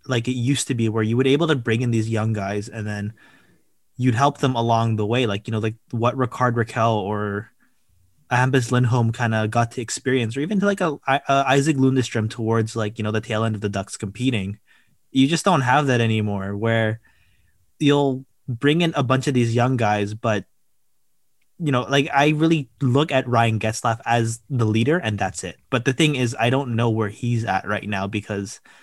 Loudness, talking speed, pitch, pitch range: -21 LUFS, 210 wpm, 115 Hz, 110-130 Hz